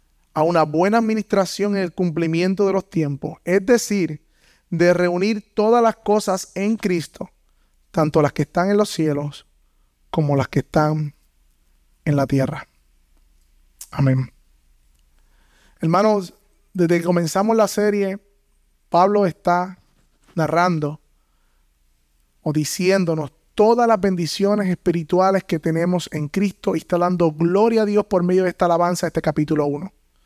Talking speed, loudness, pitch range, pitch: 135 wpm, -20 LUFS, 135-190 Hz, 170 Hz